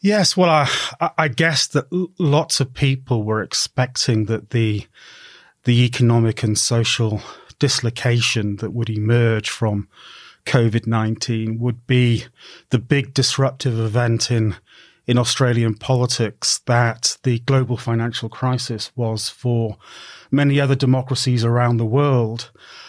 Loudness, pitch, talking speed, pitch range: -19 LUFS, 120 Hz, 120 wpm, 115-135 Hz